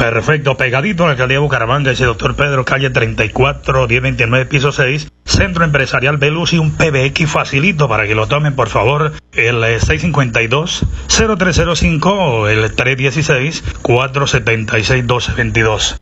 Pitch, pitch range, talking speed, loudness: 135 Hz, 120-150 Hz, 115 wpm, -13 LUFS